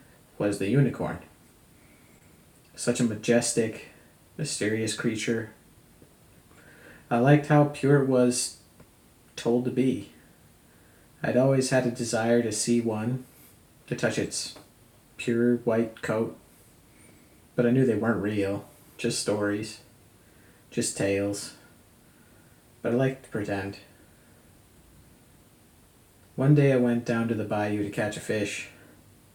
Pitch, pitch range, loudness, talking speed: 115 Hz, 105-125 Hz, -26 LUFS, 120 wpm